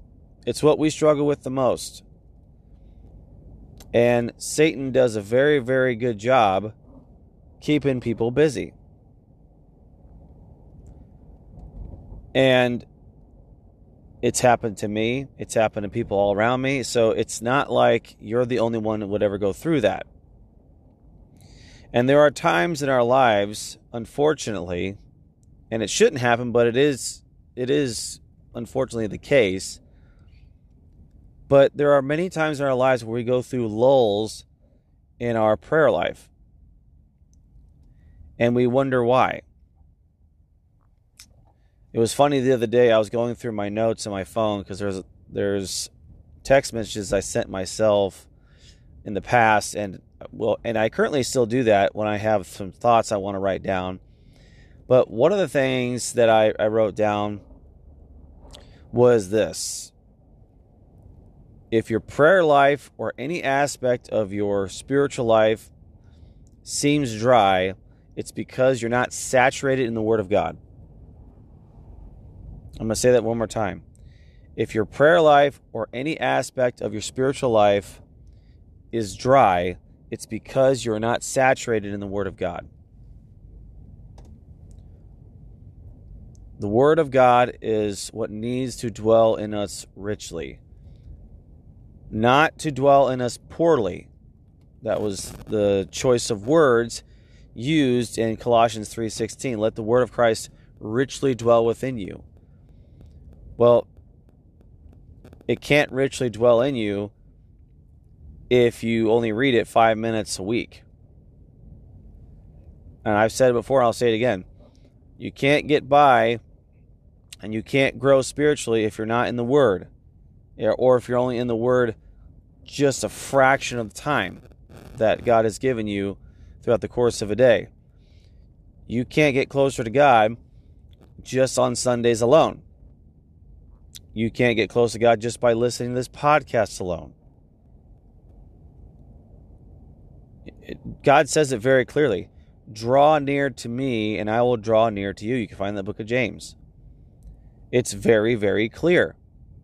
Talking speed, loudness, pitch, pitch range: 140 wpm, -21 LUFS, 115 Hz, 95-125 Hz